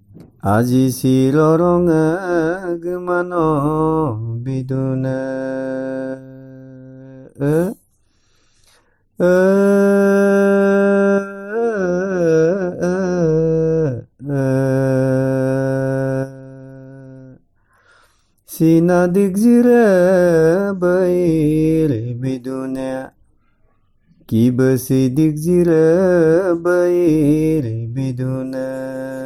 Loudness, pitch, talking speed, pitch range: -16 LUFS, 155 Hz, 40 wpm, 130-175 Hz